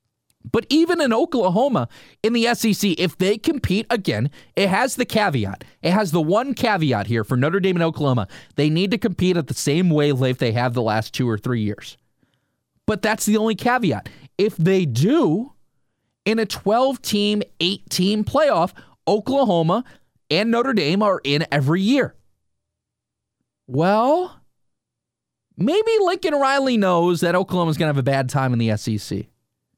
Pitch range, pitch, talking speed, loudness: 145-225 Hz, 185 Hz, 160 wpm, -20 LUFS